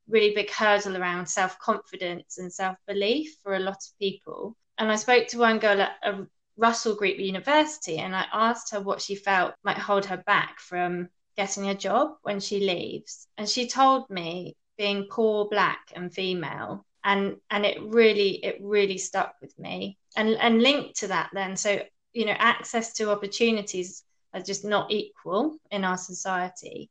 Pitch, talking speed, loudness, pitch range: 200 Hz, 175 wpm, -26 LUFS, 190-220 Hz